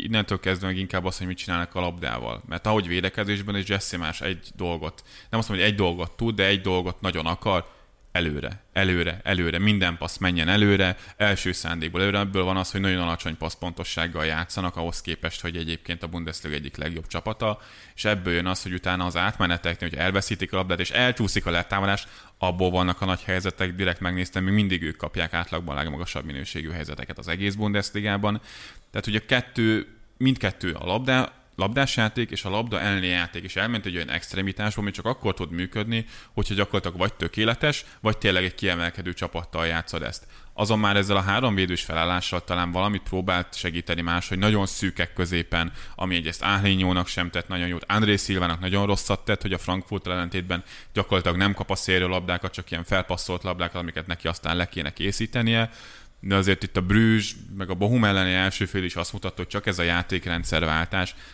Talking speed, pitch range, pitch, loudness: 190 wpm, 85-100 Hz, 95 Hz, -25 LUFS